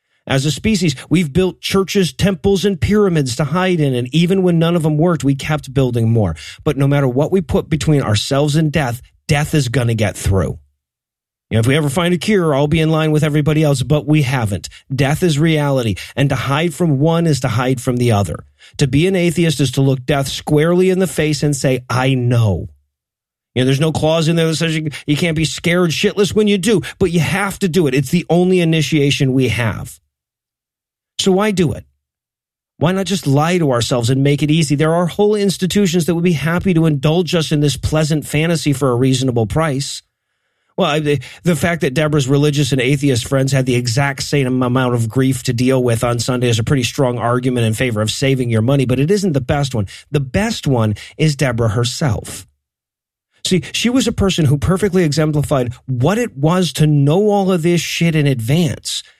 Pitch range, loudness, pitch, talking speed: 130-170 Hz, -15 LUFS, 150 Hz, 215 wpm